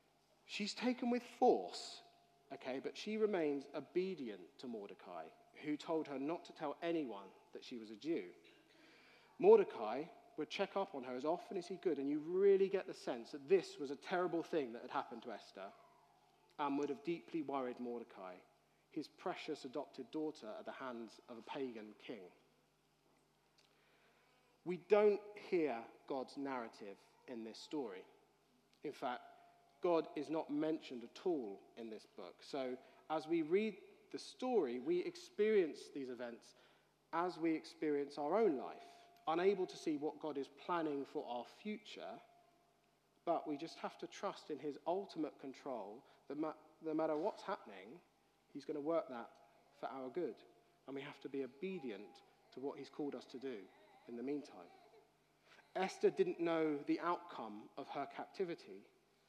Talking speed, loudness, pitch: 165 wpm, -42 LUFS, 165 Hz